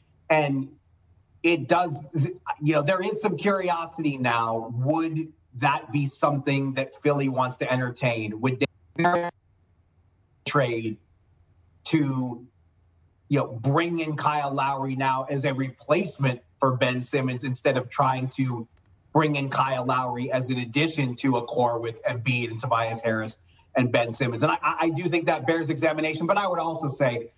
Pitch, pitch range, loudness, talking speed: 135 Hz, 120-150 Hz, -25 LUFS, 155 wpm